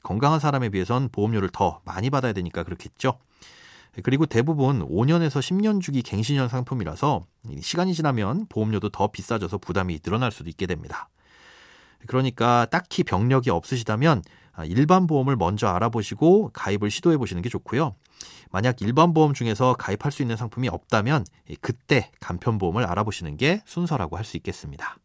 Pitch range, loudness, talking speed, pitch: 105-140 Hz, -24 LUFS, 380 characters per minute, 120 Hz